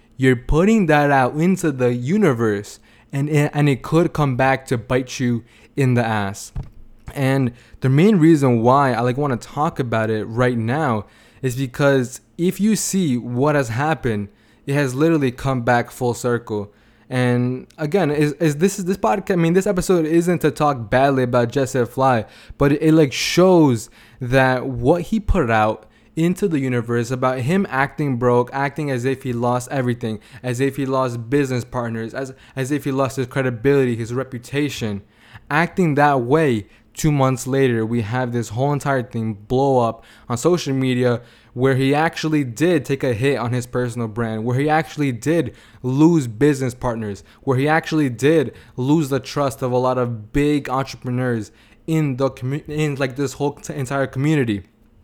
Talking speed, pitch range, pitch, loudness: 180 wpm, 120-145 Hz, 130 Hz, -19 LUFS